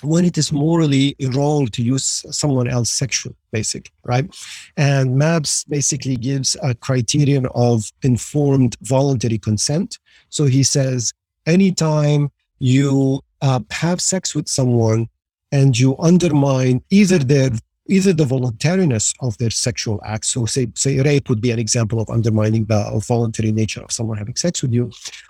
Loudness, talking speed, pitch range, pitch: -18 LUFS, 150 wpm, 115-145 Hz, 130 Hz